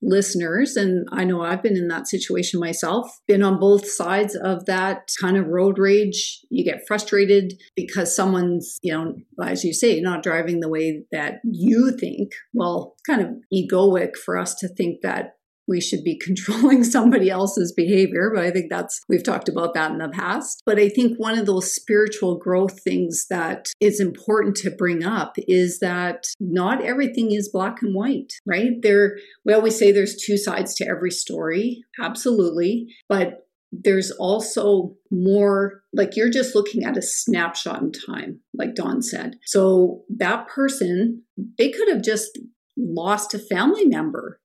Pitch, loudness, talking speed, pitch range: 200 Hz, -21 LUFS, 170 wpm, 185-220 Hz